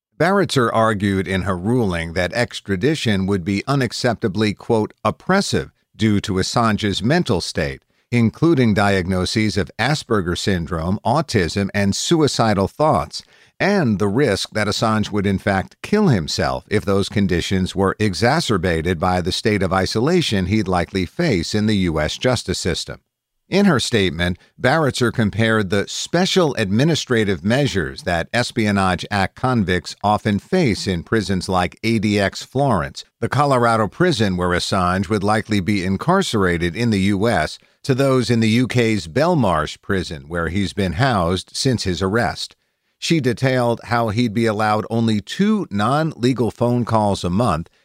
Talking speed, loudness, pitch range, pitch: 145 wpm, -19 LUFS, 95-120 Hz, 105 Hz